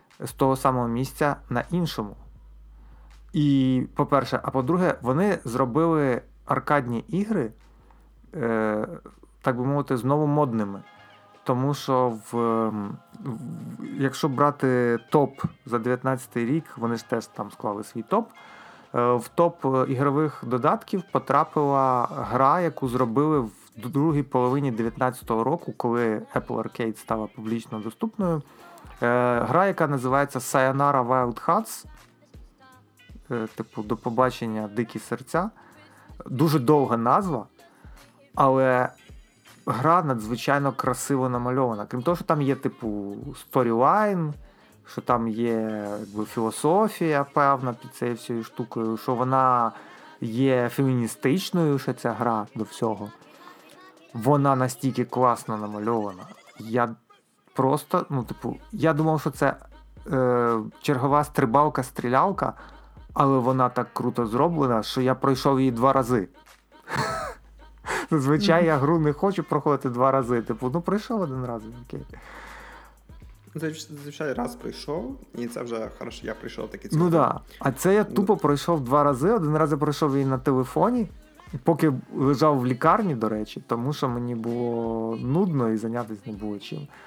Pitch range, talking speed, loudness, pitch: 120-145 Hz, 130 wpm, -24 LUFS, 130 Hz